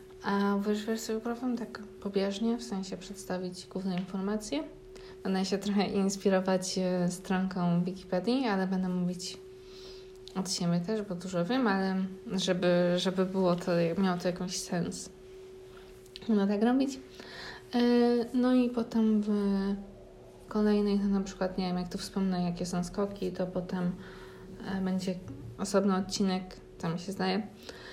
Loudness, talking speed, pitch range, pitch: -31 LUFS, 140 wpm, 185-210 Hz, 190 Hz